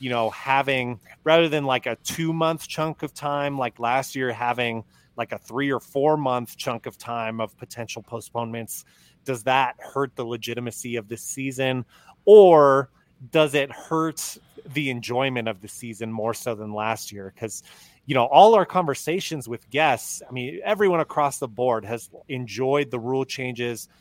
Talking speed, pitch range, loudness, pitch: 170 wpm, 115-145 Hz, -23 LUFS, 130 Hz